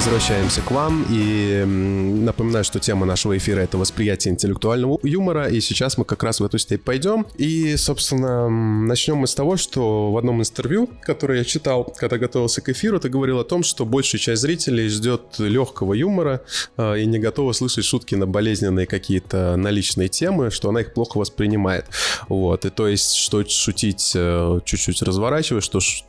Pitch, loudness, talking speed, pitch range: 115 Hz, -20 LUFS, 170 wpm, 100-130 Hz